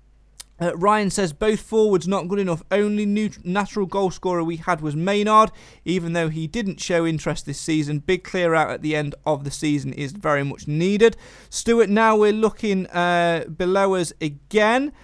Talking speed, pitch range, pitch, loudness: 185 wpm, 160-205 Hz, 180 Hz, -21 LUFS